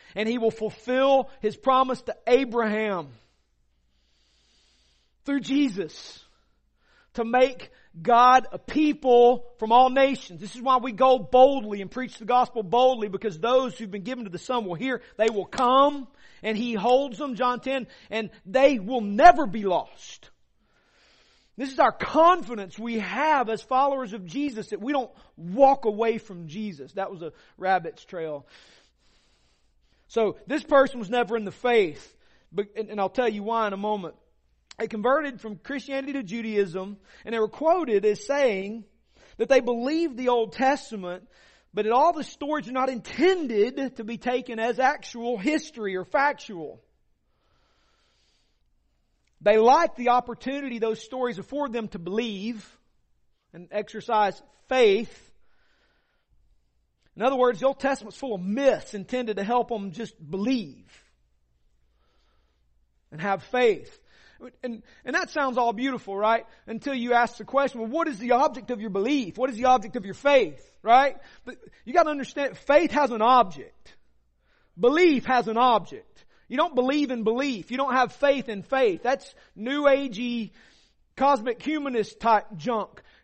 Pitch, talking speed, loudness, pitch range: 240 Hz, 155 wpm, -24 LUFS, 210-270 Hz